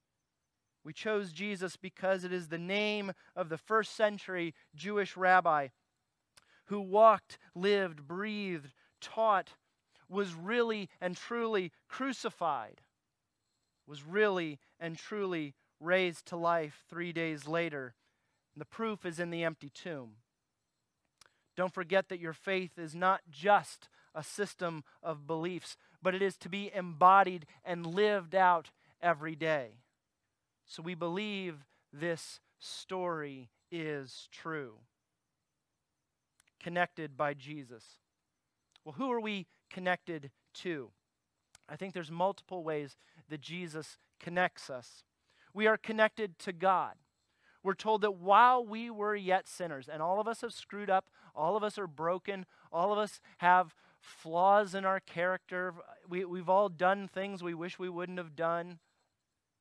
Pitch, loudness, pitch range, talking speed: 180 Hz, -33 LUFS, 160-195 Hz, 135 wpm